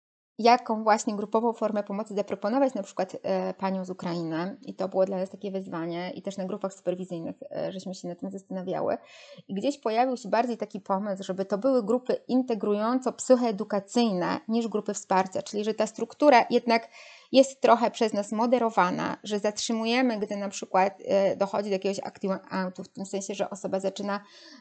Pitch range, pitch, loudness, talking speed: 190-230 Hz, 205 Hz, -27 LUFS, 175 wpm